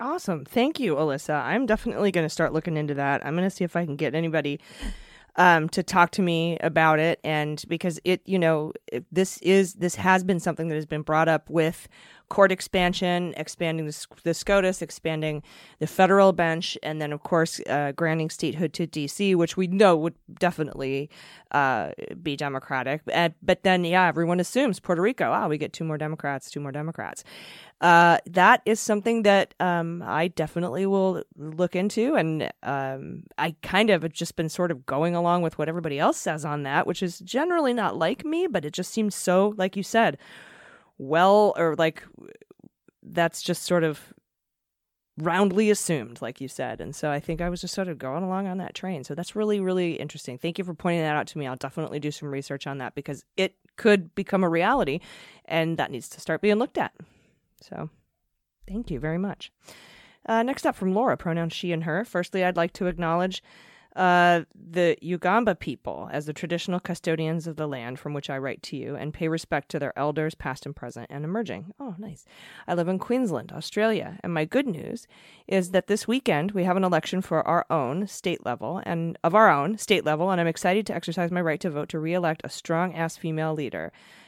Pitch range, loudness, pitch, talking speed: 155-190 Hz, -25 LUFS, 170 Hz, 205 wpm